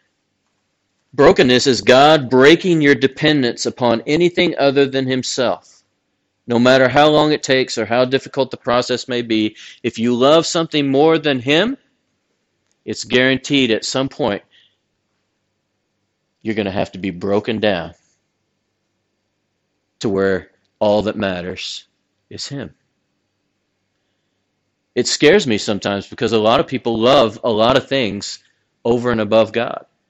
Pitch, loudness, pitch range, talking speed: 120 Hz, -16 LUFS, 105-135 Hz, 140 wpm